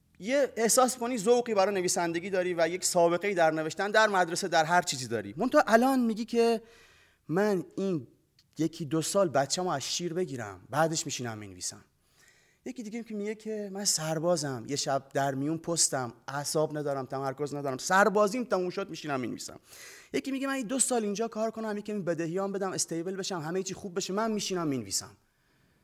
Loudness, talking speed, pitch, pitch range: -29 LUFS, 175 wpm, 180 Hz, 145-210 Hz